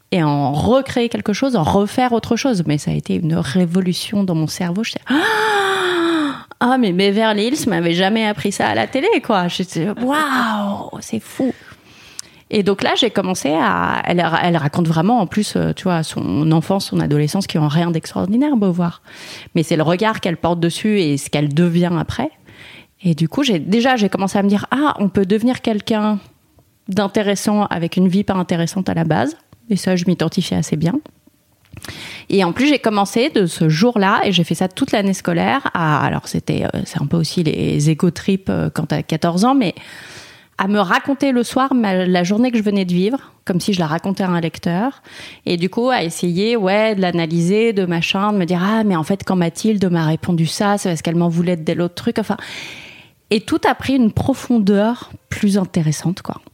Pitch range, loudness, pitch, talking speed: 170-225 Hz, -17 LUFS, 195 Hz, 205 wpm